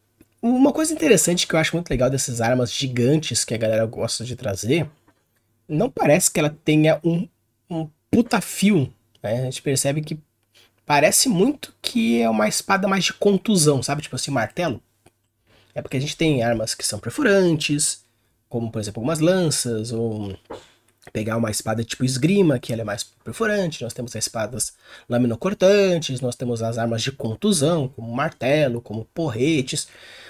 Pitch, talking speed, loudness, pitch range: 130 Hz, 165 wpm, -21 LUFS, 115-165 Hz